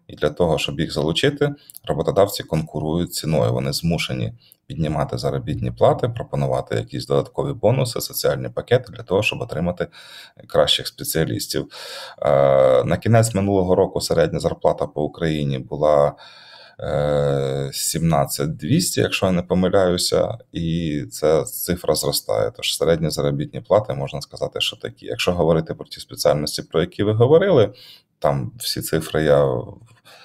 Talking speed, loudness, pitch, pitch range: 130 wpm, -20 LUFS, 75 Hz, 70-90 Hz